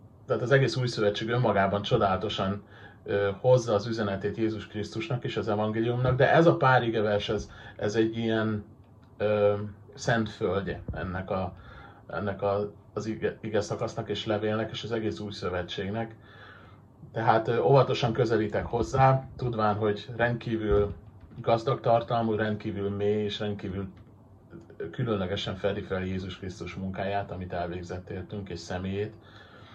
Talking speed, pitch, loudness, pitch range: 130 wpm, 105 Hz, -28 LUFS, 100-115 Hz